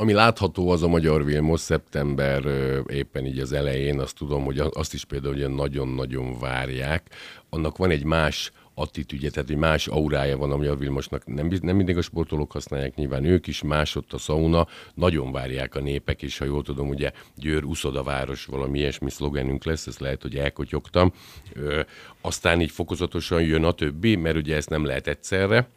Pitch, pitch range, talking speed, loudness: 75 Hz, 70-80 Hz, 185 wpm, -25 LUFS